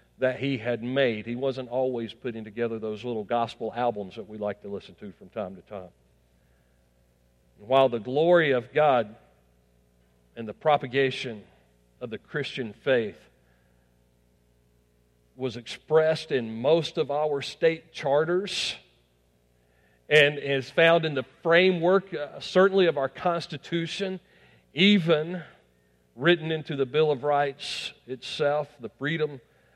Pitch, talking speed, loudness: 125 Hz, 130 wpm, -26 LUFS